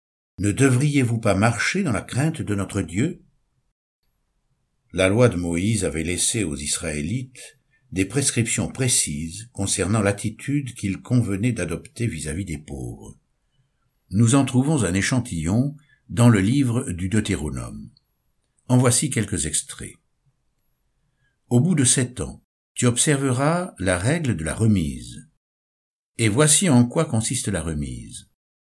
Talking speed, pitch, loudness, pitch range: 135 wpm, 110 Hz, -21 LUFS, 90-130 Hz